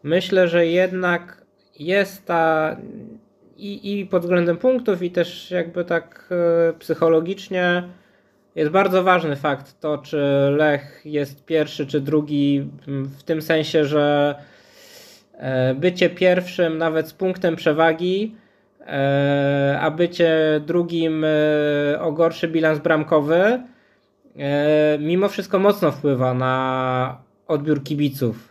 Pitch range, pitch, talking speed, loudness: 145-180 Hz, 160 Hz, 105 wpm, -20 LUFS